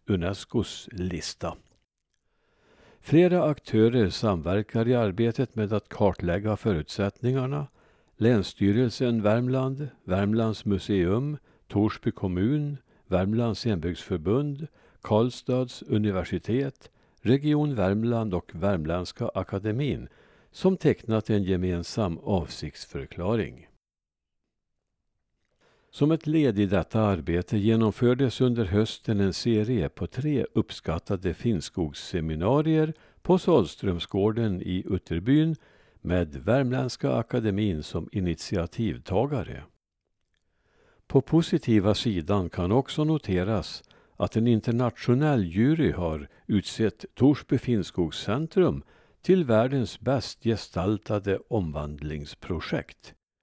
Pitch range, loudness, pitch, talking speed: 95-130 Hz, -26 LUFS, 110 Hz, 80 wpm